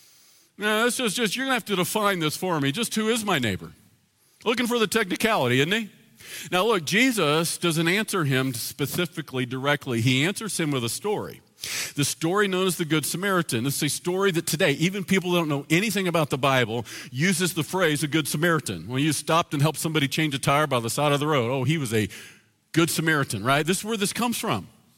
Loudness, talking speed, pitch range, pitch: -24 LUFS, 220 wpm, 140-190 Hz, 160 Hz